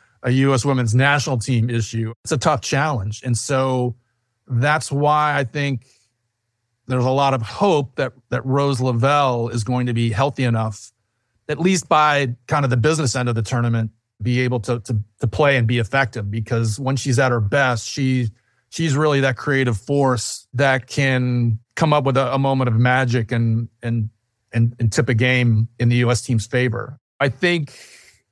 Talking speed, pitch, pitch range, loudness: 185 wpm, 125 Hz, 115-135 Hz, -19 LUFS